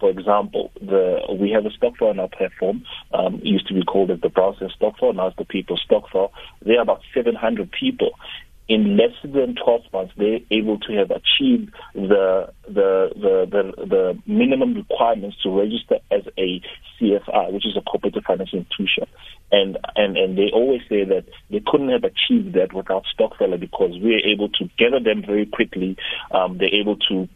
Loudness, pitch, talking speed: -20 LUFS, 210 Hz, 190 wpm